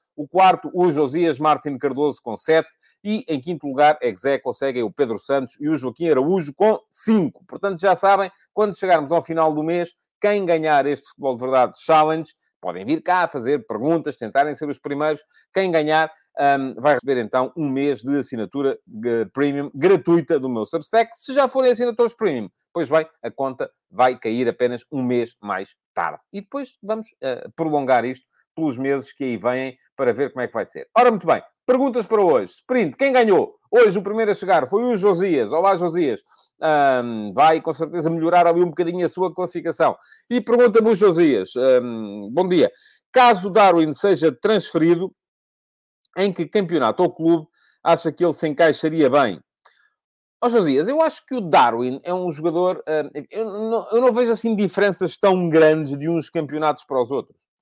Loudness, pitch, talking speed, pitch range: -20 LUFS, 165 Hz, 185 wpm, 145-205 Hz